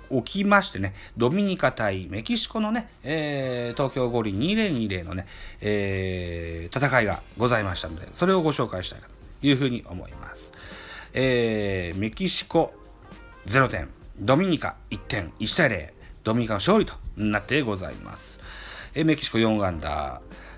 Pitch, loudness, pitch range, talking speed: 110 Hz, -25 LUFS, 95-140 Hz, 280 characters per minute